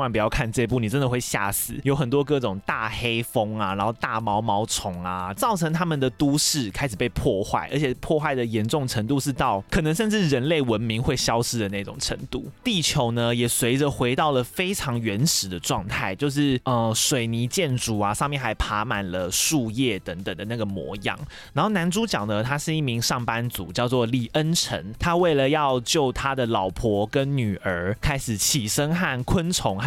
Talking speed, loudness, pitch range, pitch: 285 characters per minute, -24 LUFS, 110-145 Hz, 125 Hz